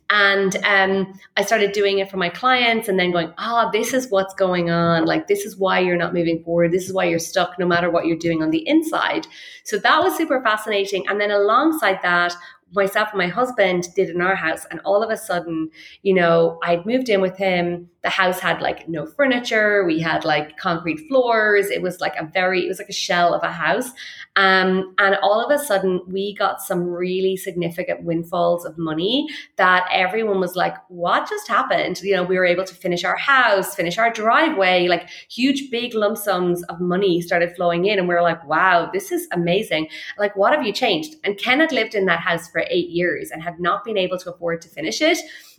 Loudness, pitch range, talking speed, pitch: -19 LUFS, 175-210 Hz, 220 wpm, 190 Hz